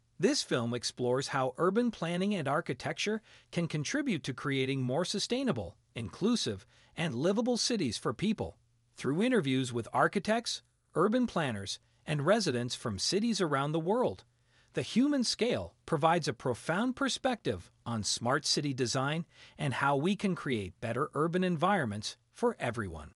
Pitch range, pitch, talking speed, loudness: 120-195 Hz, 145 Hz, 140 wpm, -32 LUFS